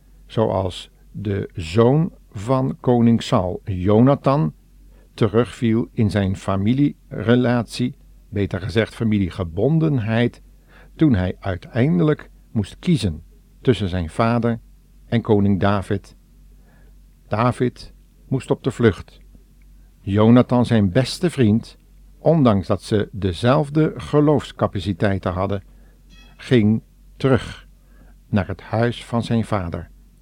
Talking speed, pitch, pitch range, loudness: 95 wpm, 110 Hz, 95-125 Hz, -20 LUFS